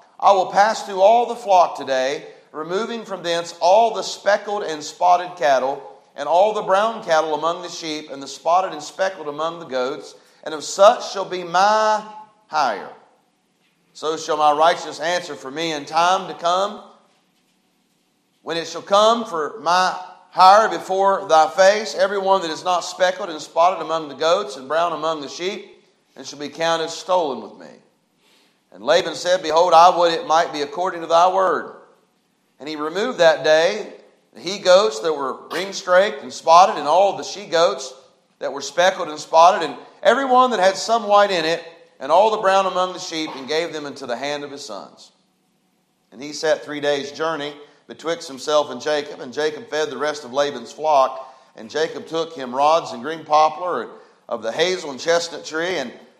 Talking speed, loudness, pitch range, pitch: 190 wpm, -19 LUFS, 150-195 Hz, 170 Hz